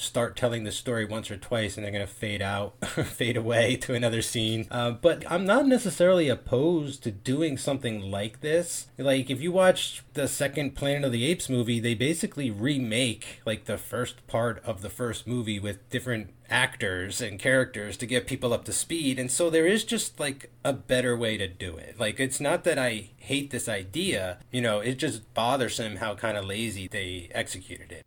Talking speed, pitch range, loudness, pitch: 200 wpm, 110-135 Hz, -28 LUFS, 120 Hz